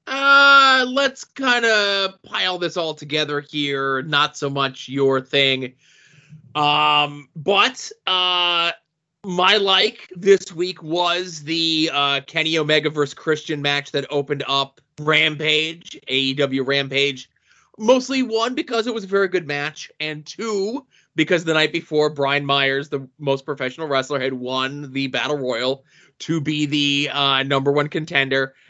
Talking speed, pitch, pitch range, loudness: 140 wpm, 150 Hz, 140-180 Hz, -19 LUFS